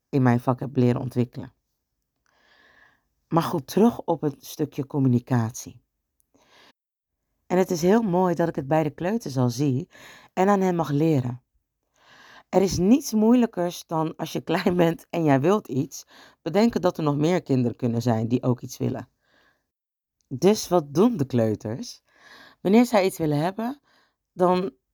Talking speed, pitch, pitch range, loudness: 160 wpm, 160 Hz, 130-185 Hz, -23 LUFS